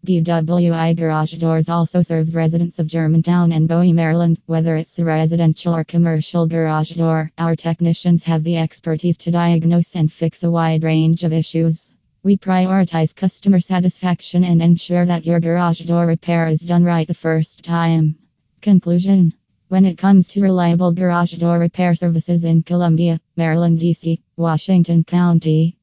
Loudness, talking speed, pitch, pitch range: -16 LUFS, 155 wpm, 170 Hz, 165-175 Hz